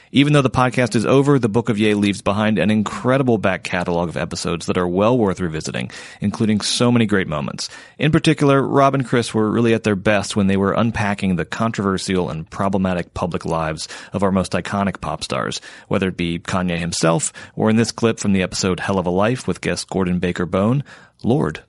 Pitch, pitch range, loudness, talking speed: 100 Hz, 90-115 Hz, -19 LUFS, 210 wpm